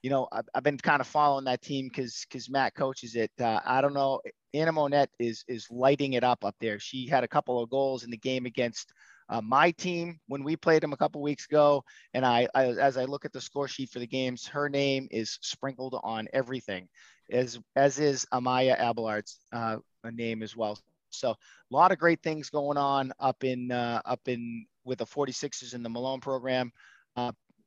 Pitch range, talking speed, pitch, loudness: 120-140 Hz, 215 wpm, 130 Hz, -29 LUFS